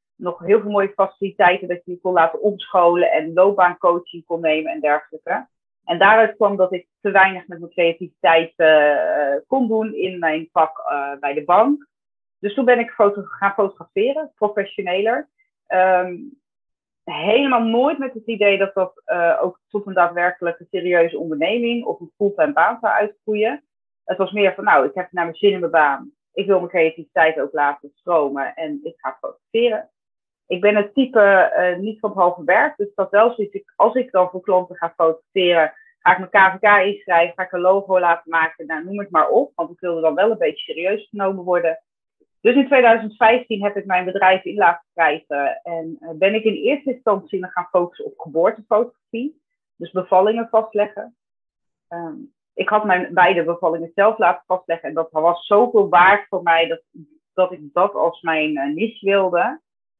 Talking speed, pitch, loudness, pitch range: 190 wpm, 190 Hz, -18 LUFS, 170-220 Hz